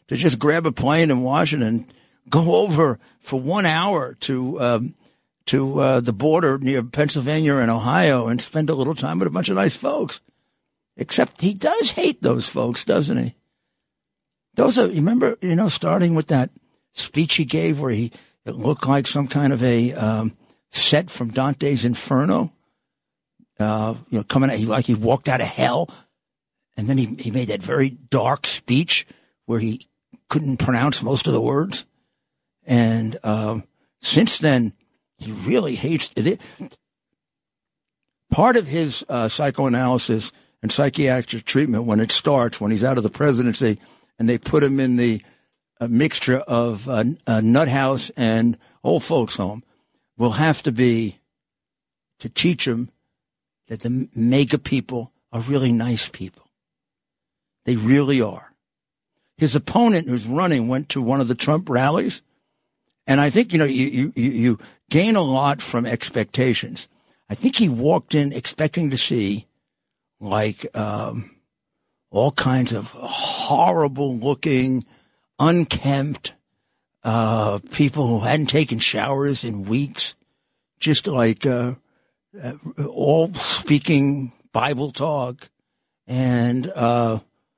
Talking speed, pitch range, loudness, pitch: 145 wpm, 120-145 Hz, -20 LUFS, 130 Hz